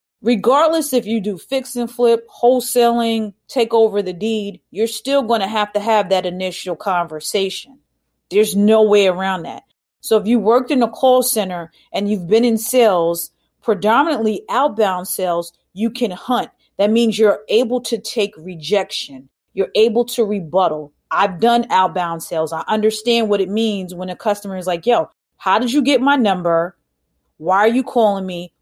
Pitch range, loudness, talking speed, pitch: 185-235 Hz, -17 LUFS, 175 wpm, 215 Hz